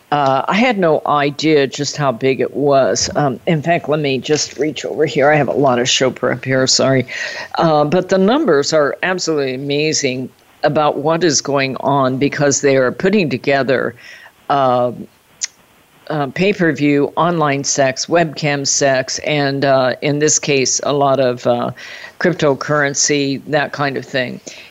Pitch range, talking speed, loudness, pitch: 135-155 Hz, 165 wpm, -15 LUFS, 140 Hz